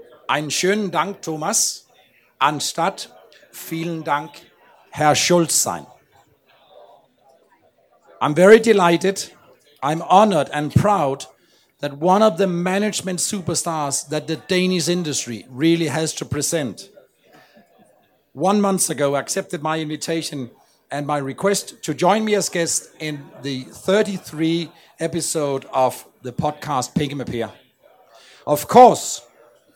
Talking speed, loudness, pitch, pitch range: 105 wpm, -19 LUFS, 160 Hz, 145-185 Hz